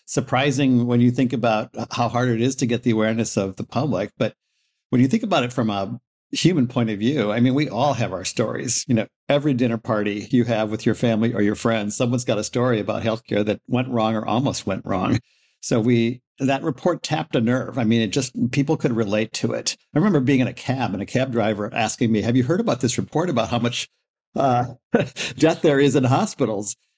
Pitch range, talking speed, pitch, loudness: 110-130 Hz, 230 wpm, 120 Hz, -21 LUFS